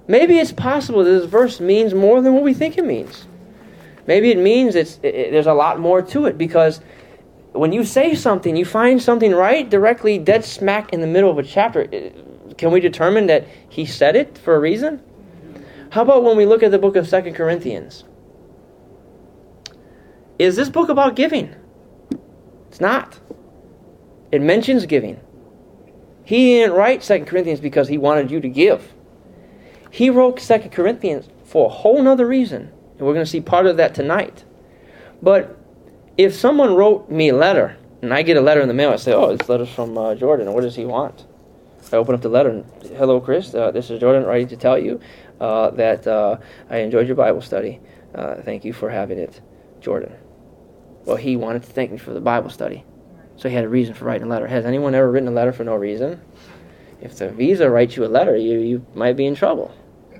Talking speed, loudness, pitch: 200 wpm, -16 LUFS, 180 Hz